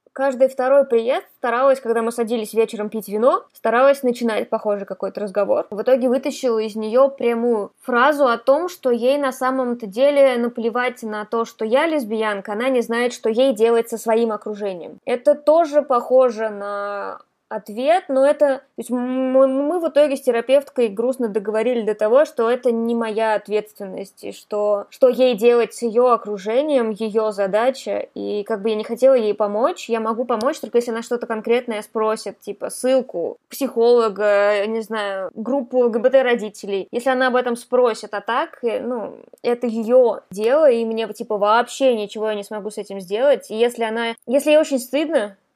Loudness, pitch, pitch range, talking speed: -19 LUFS, 235 Hz, 220-260 Hz, 175 wpm